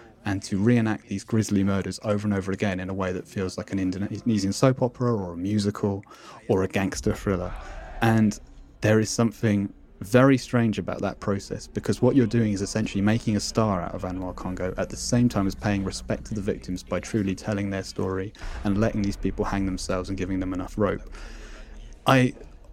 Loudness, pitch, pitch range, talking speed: -26 LUFS, 100 Hz, 95-110 Hz, 200 wpm